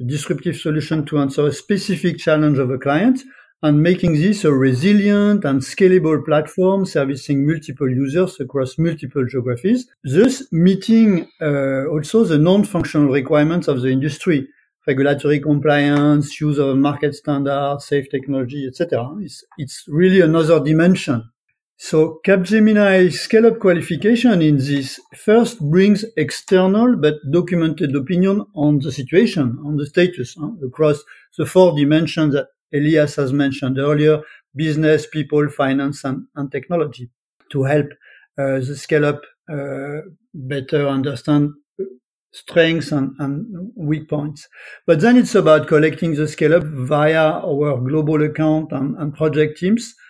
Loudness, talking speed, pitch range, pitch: -17 LUFS, 130 wpm, 140-175 Hz, 150 Hz